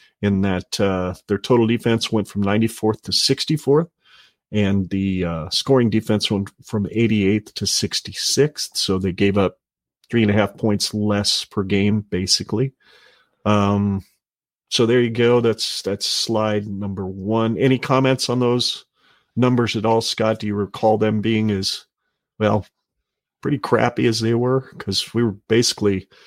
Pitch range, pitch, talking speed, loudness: 100-120 Hz, 110 Hz, 155 wpm, -20 LUFS